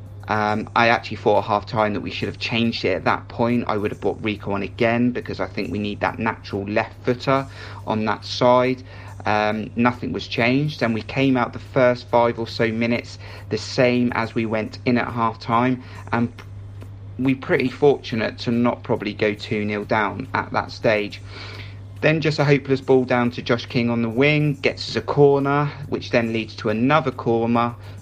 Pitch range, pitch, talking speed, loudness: 105-125 Hz, 115 Hz, 195 wpm, -21 LUFS